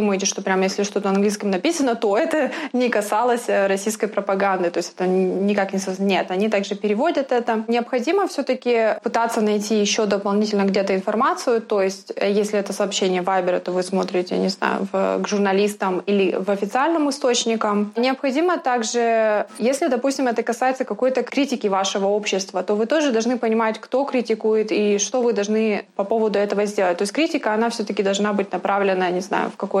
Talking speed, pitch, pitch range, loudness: 175 wpm, 210 Hz, 195-240 Hz, -21 LUFS